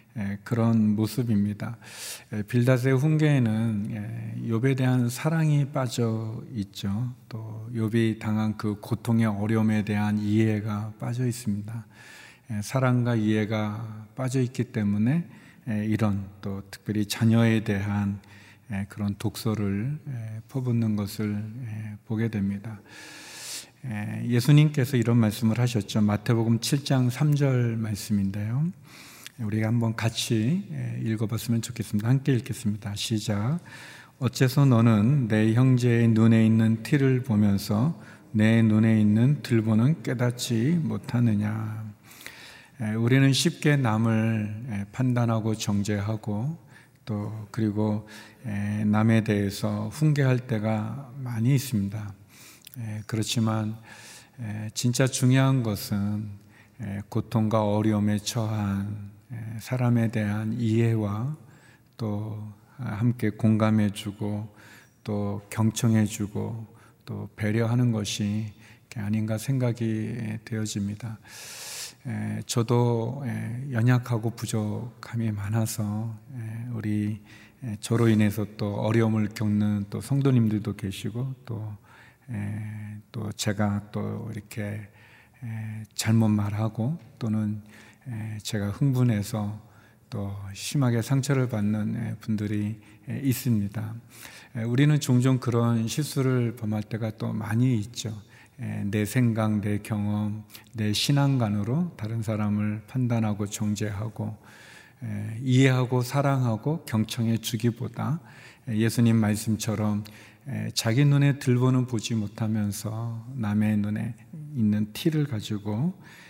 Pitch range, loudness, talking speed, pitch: 105-120 Hz, -26 LUFS, 225 characters per minute, 110 Hz